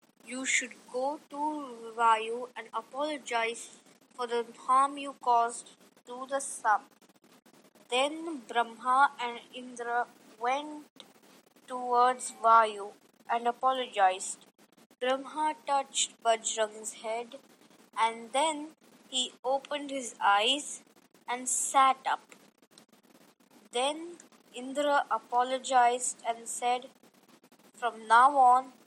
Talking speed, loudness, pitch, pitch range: 95 wpm, -29 LUFS, 250 Hz, 235-270 Hz